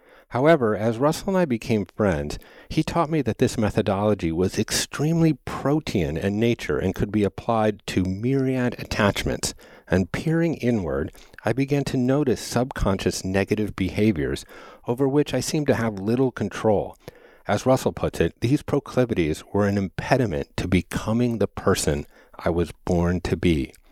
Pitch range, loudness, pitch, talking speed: 95-135 Hz, -23 LUFS, 110 Hz, 155 wpm